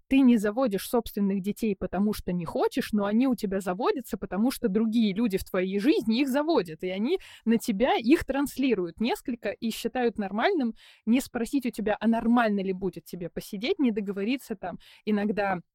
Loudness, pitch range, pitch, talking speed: -27 LUFS, 200-245 Hz, 225 Hz, 180 wpm